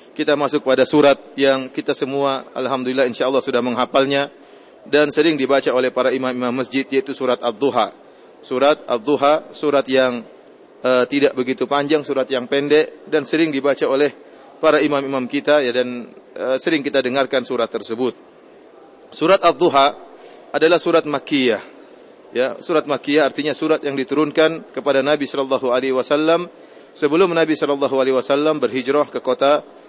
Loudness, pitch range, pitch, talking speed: -18 LUFS, 130-150 Hz, 140 Hz, 145 wpm